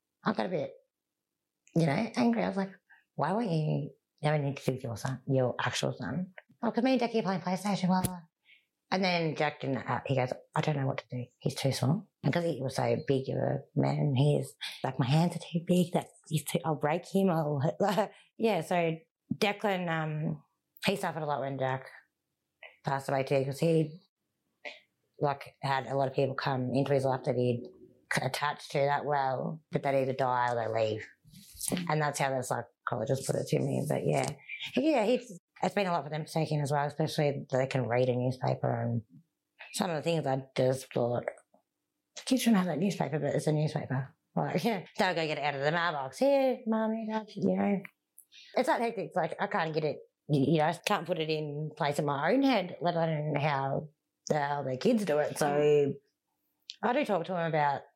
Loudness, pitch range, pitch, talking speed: -31 LUFS, 135-185 Hz, 155 Hz, 215 wpm